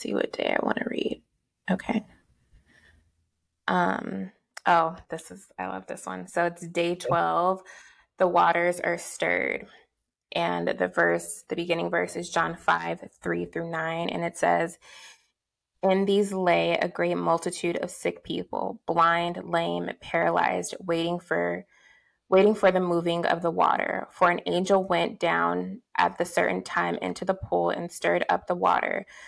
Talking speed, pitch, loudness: 160 wpm, 170 Hz, -26 LUFS